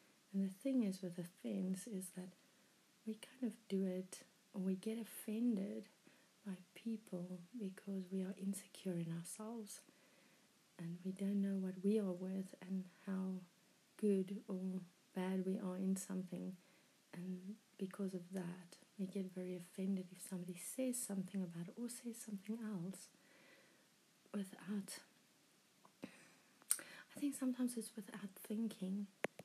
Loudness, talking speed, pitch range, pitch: -45 LUFS, 135 wpm, 185-215 Hz, 195 Hz